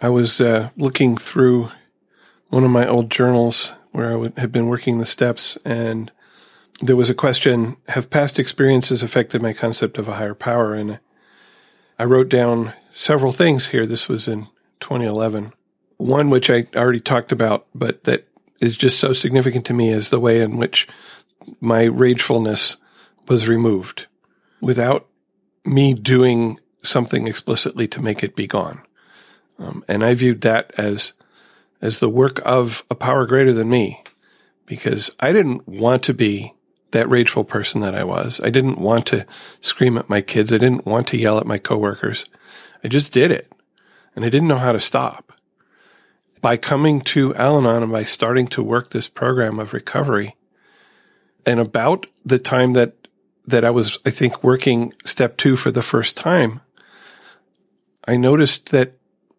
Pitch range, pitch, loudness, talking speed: 115-130 Hz, 120 Hz, -17 LUFS, 165 wpm